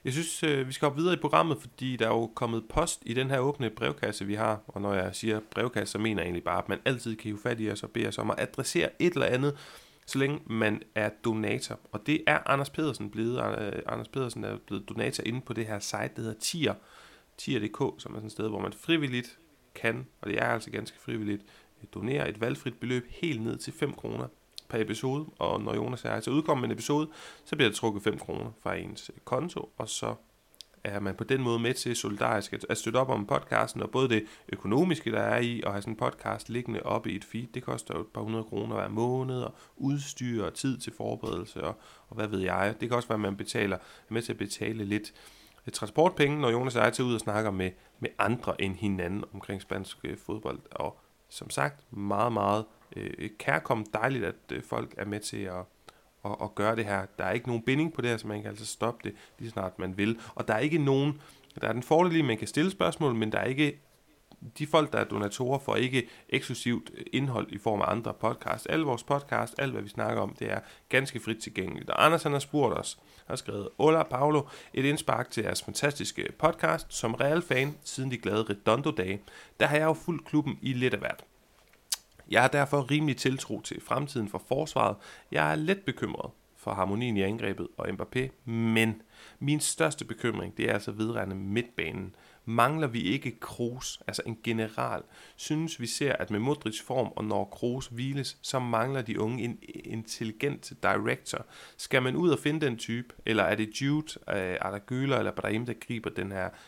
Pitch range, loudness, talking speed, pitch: 105-135 Hz, -31 LUFS, 220 wpm, 115 Hz